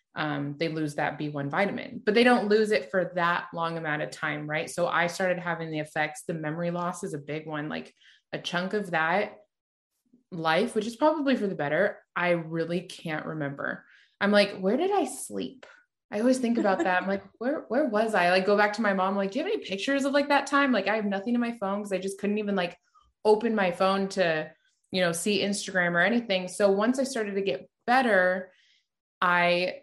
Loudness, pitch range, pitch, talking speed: -27 LUFS, 170-215 Hz, 190 Hz, 225 wpm